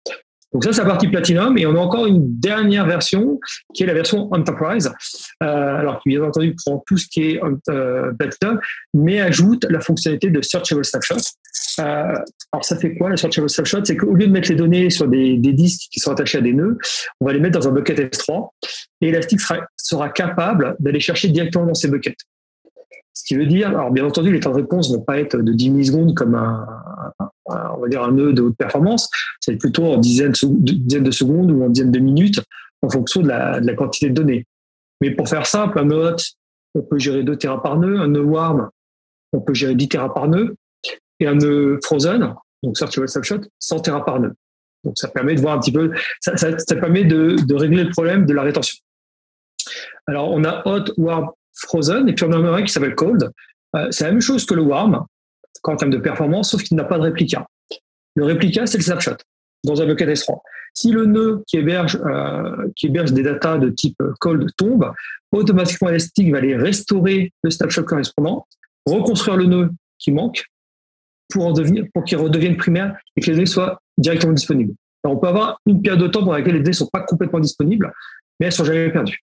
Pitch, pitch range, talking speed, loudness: 165 Hz, 145-185 Hz, 220 wpm, -17 LUFS